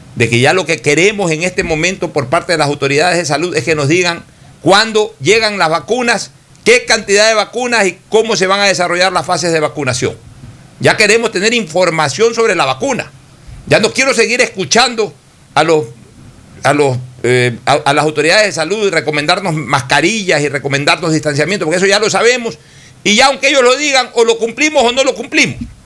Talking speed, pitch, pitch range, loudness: 195 wpm, 175 Hz, 150-220 Hz, -11 LUFS